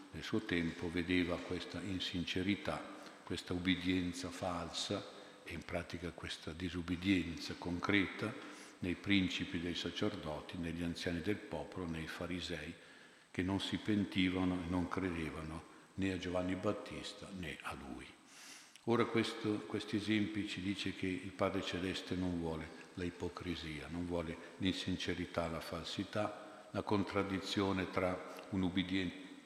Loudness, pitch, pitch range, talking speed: -39 LUFS, 90 Hz, 85-100 Hz, 130 wpm